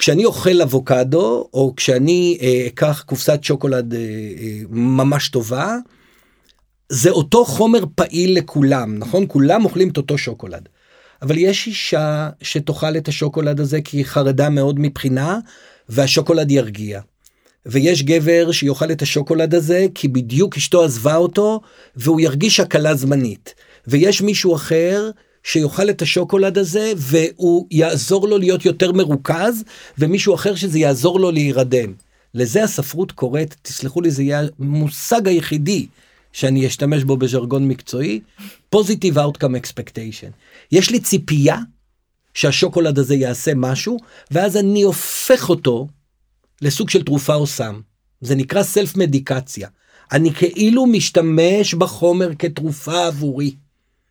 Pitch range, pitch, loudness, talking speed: 135-185 Hz, 155 Hz, -16 LUFS, 130 wpm